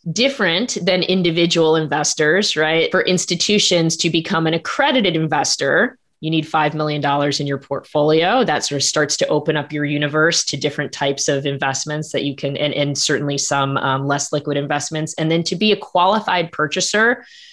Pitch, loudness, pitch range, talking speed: 155 Hz, -17 LUFS, 145-175 Hz, 175 wpm